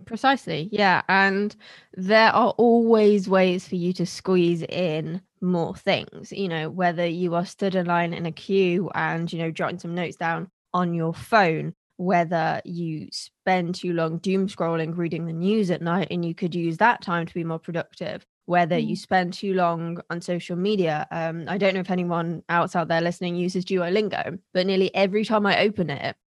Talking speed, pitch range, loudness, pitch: 190 wpm, 170-195 Hz, -23 LUFS, 180 Hz